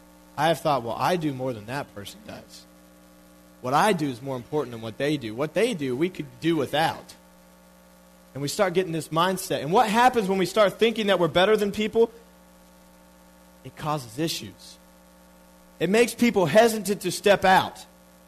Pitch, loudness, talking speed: 135 Hz, -24 LUFS, 185 wpm